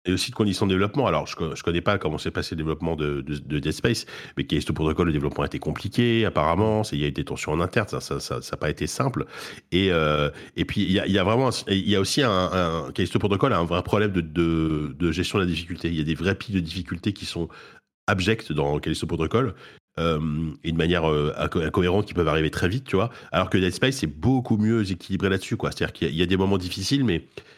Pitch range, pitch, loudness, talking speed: 80-100 Hz, 90 Hz, -24 LUFS, 250 wpm